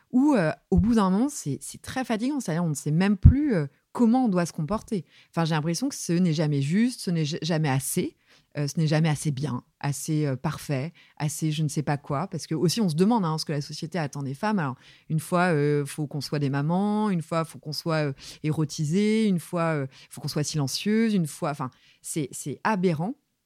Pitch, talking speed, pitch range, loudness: 160 Hz, 245 wpm, 145-190 Hz, -26 LUFS